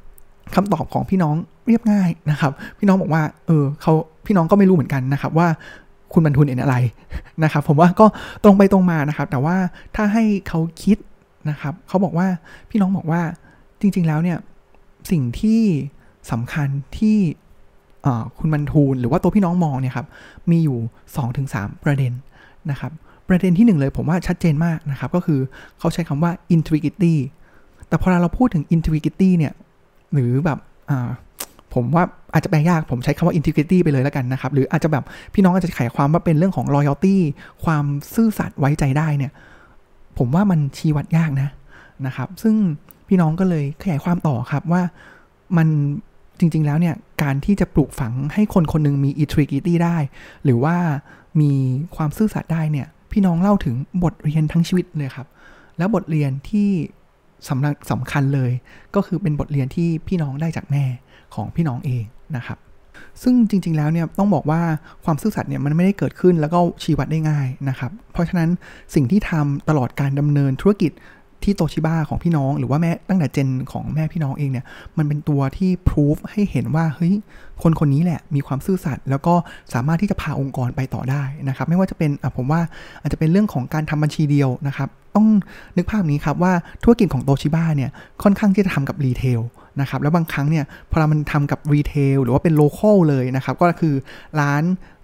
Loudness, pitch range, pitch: -19 LUFS, 140-175 Hz, 155 Hz